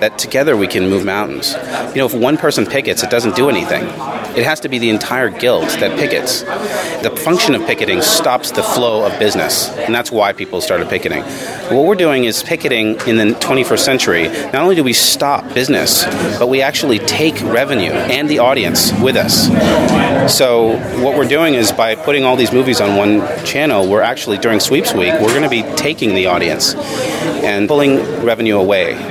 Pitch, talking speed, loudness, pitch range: 115 Hz, 190 wpm, -13 LUFS, 105-130 Hz